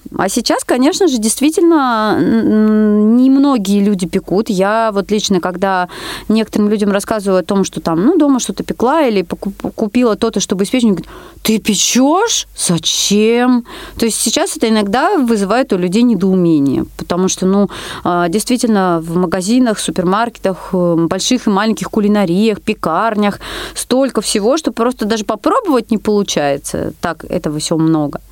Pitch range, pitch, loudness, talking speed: 190-245 Hz, 215 Hz, -14 LUFS, 140 wpm